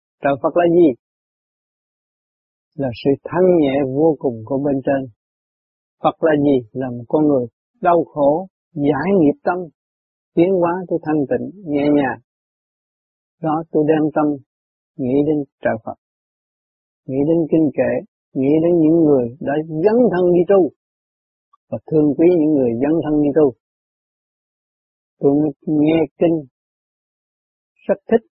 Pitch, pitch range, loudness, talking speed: 150 Hz, 140-165 Hz, -17 LUFS, 140 wpm